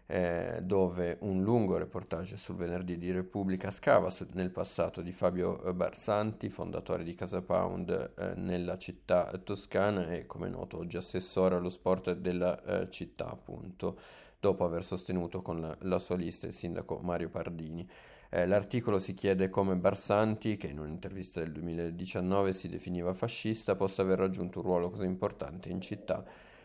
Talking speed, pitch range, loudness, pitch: 155 wpm, 90-95 Hz, -34 LUFS, 90 Hz